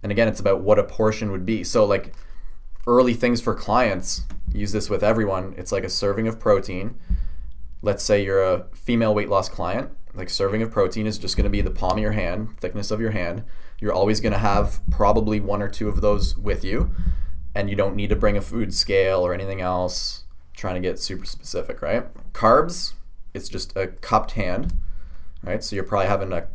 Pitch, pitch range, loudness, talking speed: 100 Hz, 85-105 Hz, -23 LUFS, 215 wpm